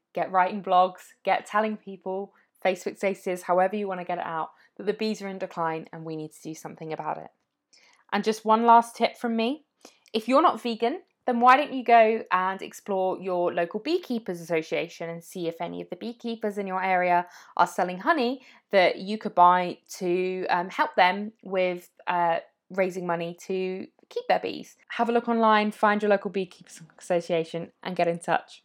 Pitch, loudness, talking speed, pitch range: 190 Hz, -26 LUFS, 195 wpm, 175-220 Hz